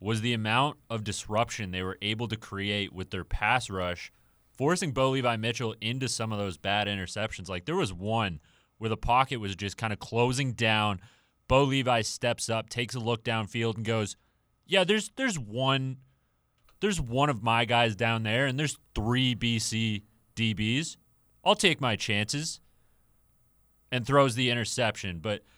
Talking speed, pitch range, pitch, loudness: 170 wpm, 105-130 Hz, 115 Hz, -28 LUFS